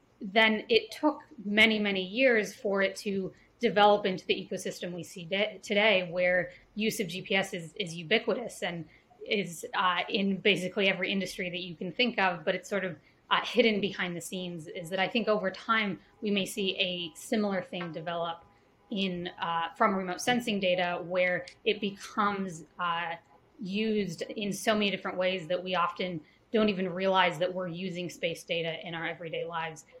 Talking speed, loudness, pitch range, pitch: 180 wpm, -30 LUFS, 180-210 Hz, 190 Hz